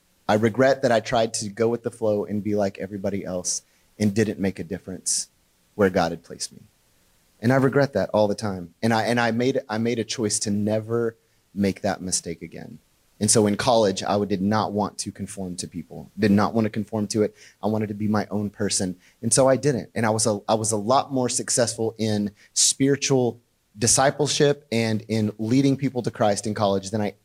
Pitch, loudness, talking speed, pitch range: 110 Hz, -23 LUFS, 220 wpm, 100-115 Hz